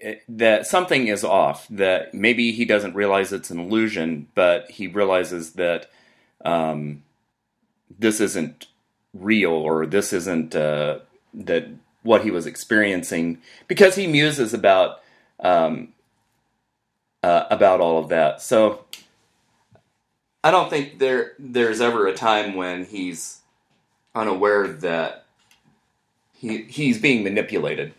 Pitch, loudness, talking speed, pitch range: 105 Hz, -20 LUFS, 120 wpm, 85-115 Hz